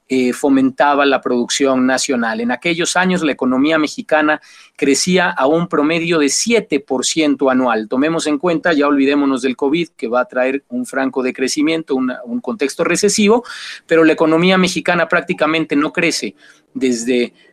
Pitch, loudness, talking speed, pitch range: 150 Hz, -15 LUFS, 150 wpm, 130-165 Hz